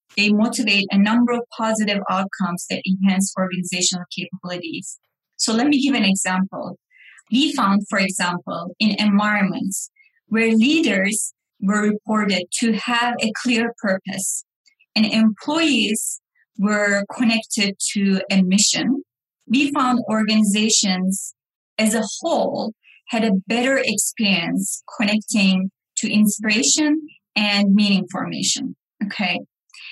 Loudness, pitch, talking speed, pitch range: -19 LUFS, 215 Hz, 110 wpm, 195-235 Hz